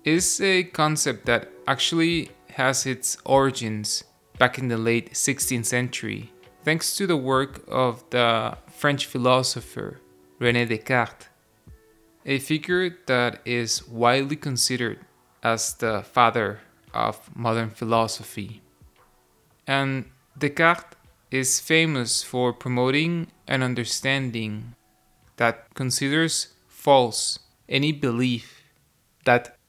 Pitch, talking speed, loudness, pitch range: 125 Hz, 100 wpm, -23 LUFS, 115-145 Hz